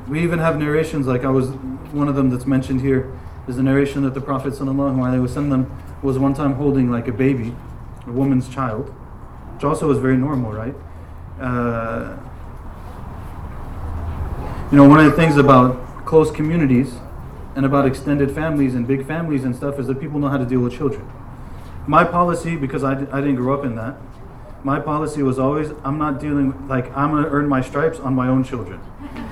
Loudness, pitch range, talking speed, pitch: -18 LUFS, 125-145 Hz, 195 wpm, 135 Hz